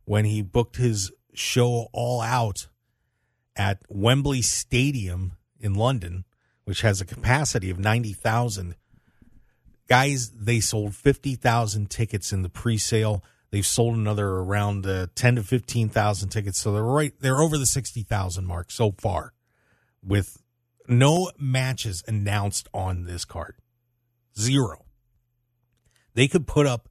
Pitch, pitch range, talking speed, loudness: 115 Hz, 100-120 Hz, 130 wpm, -24 LUFS